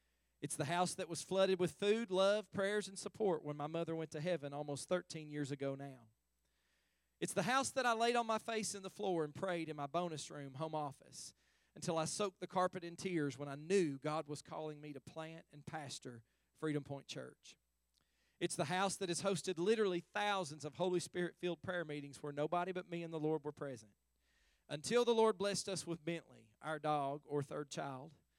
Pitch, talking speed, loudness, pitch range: 160 Hz, 210 wpm, -40 LUFS, 145-185 Hz